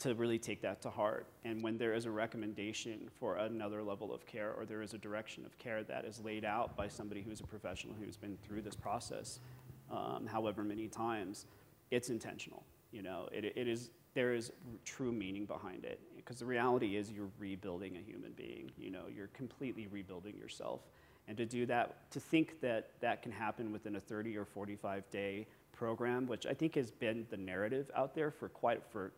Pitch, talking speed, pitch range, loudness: 110 Hz, 205 wpm, 105-120 Hz, -42 LUFS